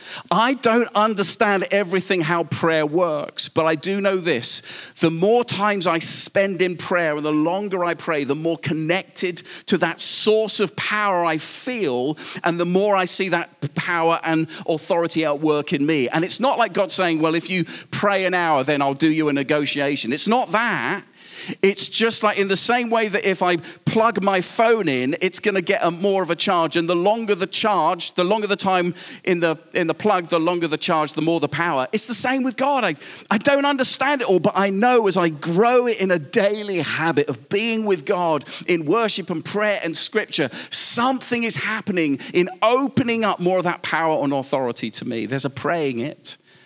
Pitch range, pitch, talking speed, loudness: 165-210 Hz, 185 Hz, 210 wpm, -20 LUFS